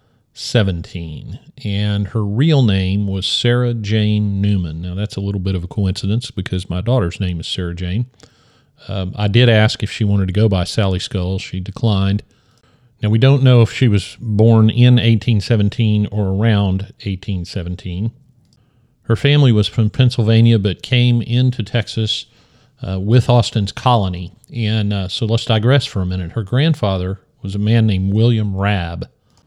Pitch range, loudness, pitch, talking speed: 95-120 Hz, -16 LUFS, 110 Hz, 165 wpm